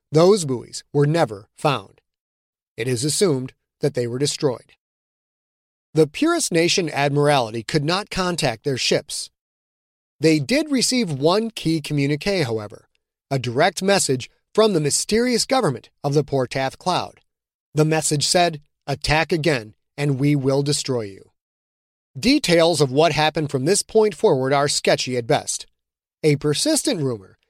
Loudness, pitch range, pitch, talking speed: -20 LUFS, 135-175 Hz, 150 Hz, 140 wpm